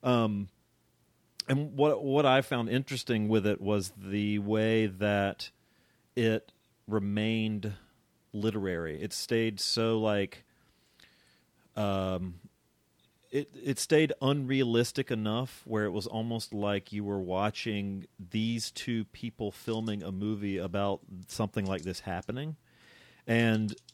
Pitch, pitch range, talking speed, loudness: 110 Hz, 100-115 Hz, 115 wpm, -31 LUFS